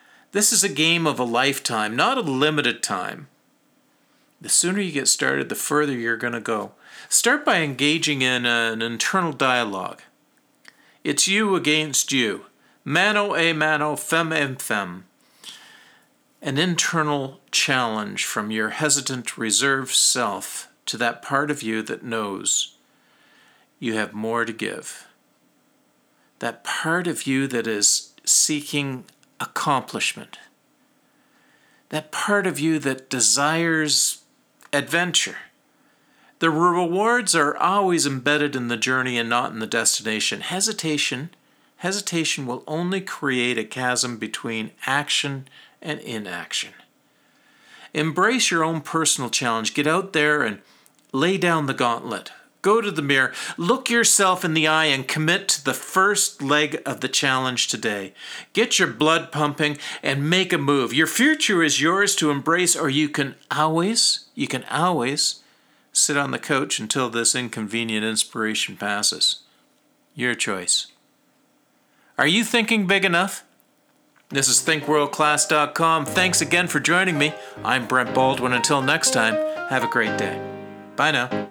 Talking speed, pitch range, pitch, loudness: 140 wpm, 130-175 Hz, 150 Hz, -21 LUFS